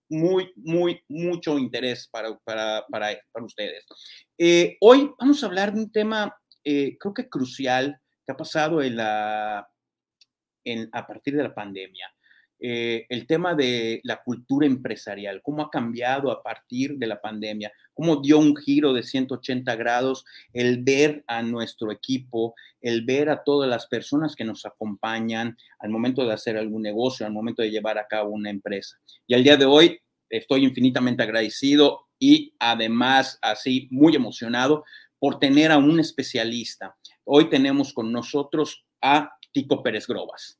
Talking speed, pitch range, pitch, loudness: 160 wpm, 115-150 Hz, 130 Hz, -23 LUFS